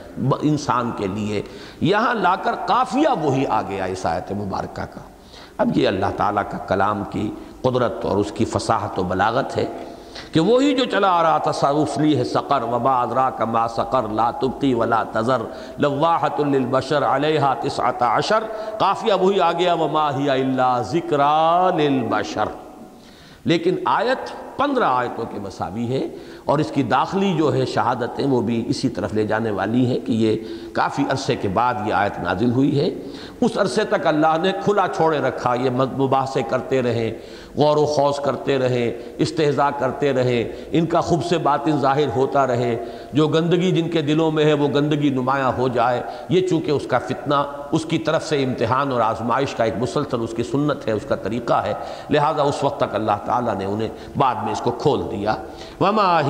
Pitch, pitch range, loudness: 140 Hz, 120-155 Hz, -20 LUFS